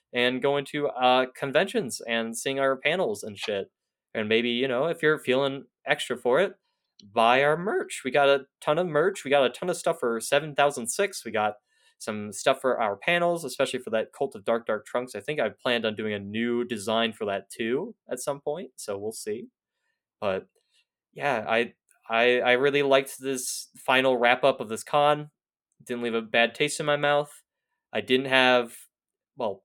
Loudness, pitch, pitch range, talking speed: -26 LUFS, 135 Hz, 120-150 Hz, 200 wpm